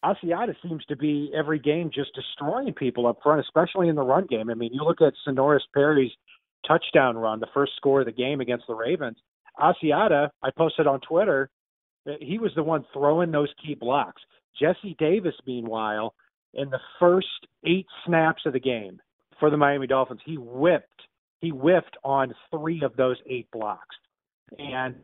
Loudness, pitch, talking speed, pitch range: -25 LUFS, 145 Hz, 175 wpm, 130-160 Hz